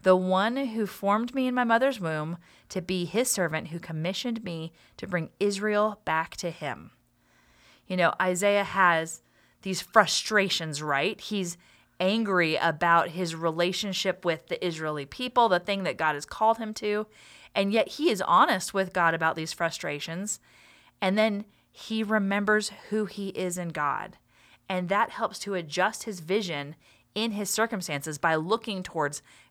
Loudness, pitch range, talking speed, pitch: -27 LUFS, 165-210 Hz, 160 wpm, 185 Hz